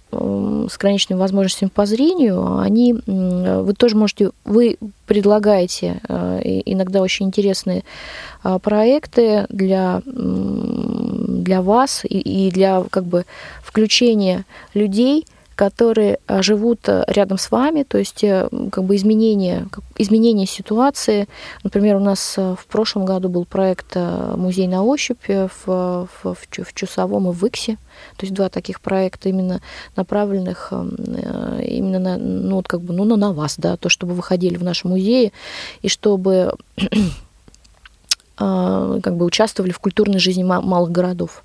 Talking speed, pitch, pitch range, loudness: 130 wpm, 195 Hz, 185-220 Hz, -18 LUFS